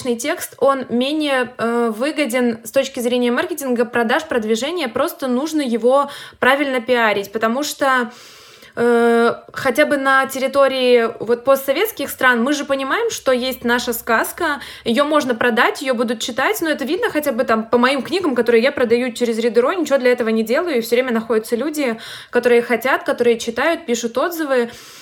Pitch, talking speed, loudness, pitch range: 255 Hz, 165 wpm, -17 LUFS, 240-275 Hz